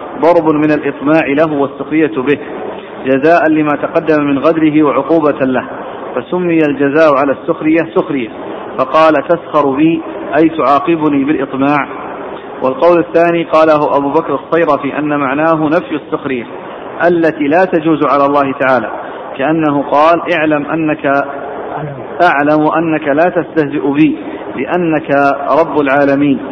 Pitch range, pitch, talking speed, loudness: 140-165 Hz, 150 Hz, 120 wpm, -12 LUFS